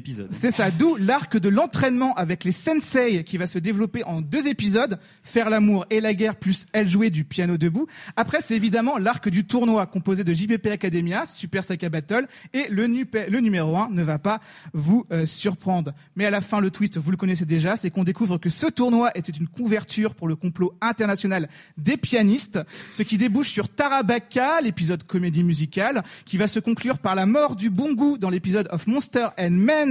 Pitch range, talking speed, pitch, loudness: 180-230 Hz, 205 wpm, 205 Hz, -23 LUFS